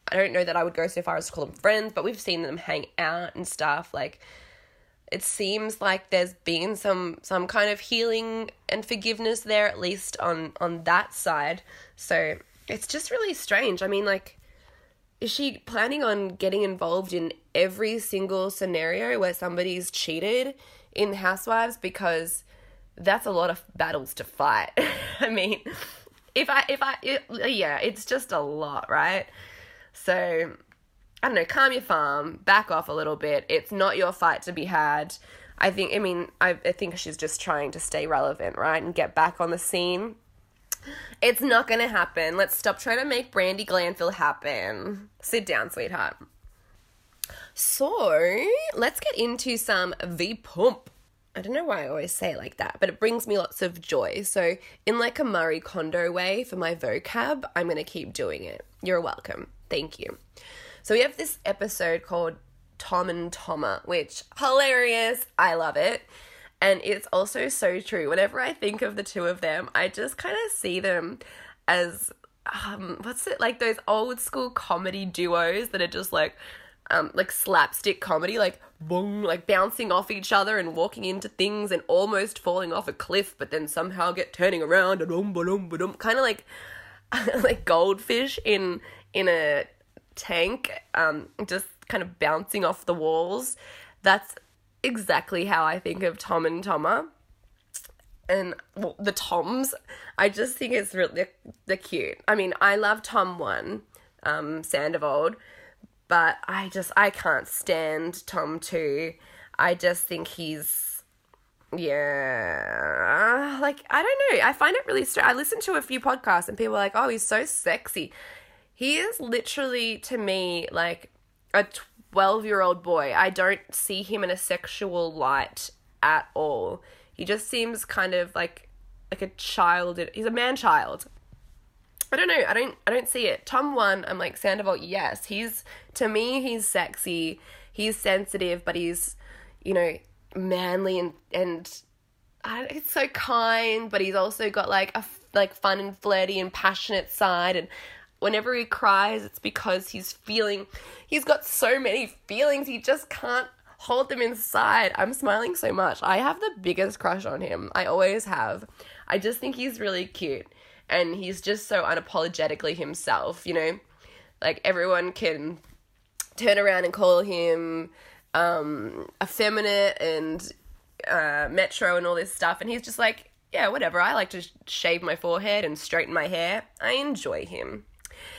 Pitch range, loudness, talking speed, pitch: 175-240 Hz, -26 LUFS, 170 wpm, 195 Hz